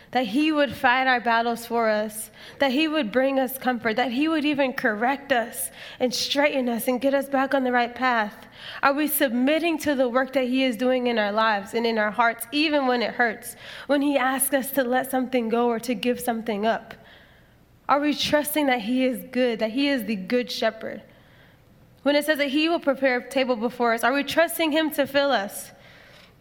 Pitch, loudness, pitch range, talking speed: 255 Hz, -23 LUFS, 240-280 Hz, 220 wpm